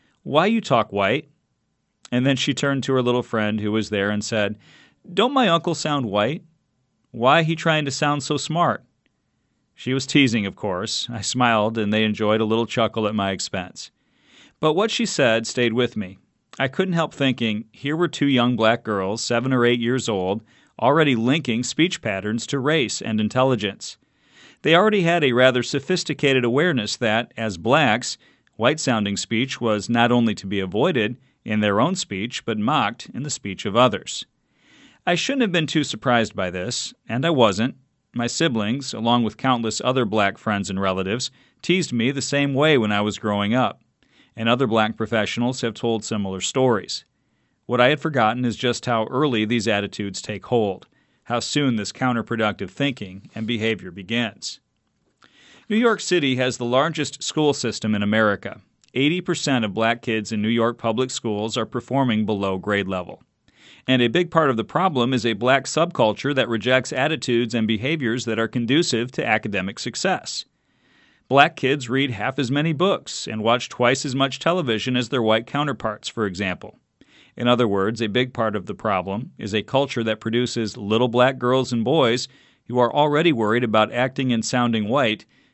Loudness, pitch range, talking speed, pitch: -21 LUFS, 110-135 Hz, 180 wpm, 120 Hz